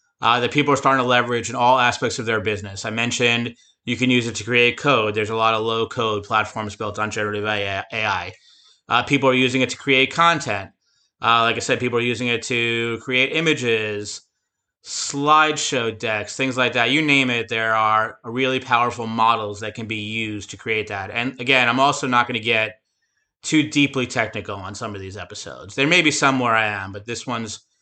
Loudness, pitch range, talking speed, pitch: -19 LUFS, 110-130 Hz, 210 wpm, 115 Hz